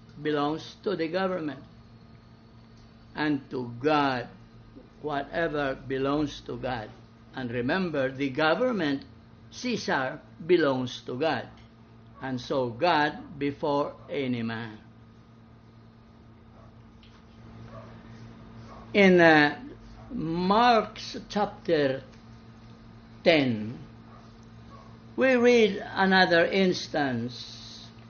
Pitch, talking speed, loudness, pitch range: 120 Hz, 75 wpm, -26 LUFS, 115-150 Hz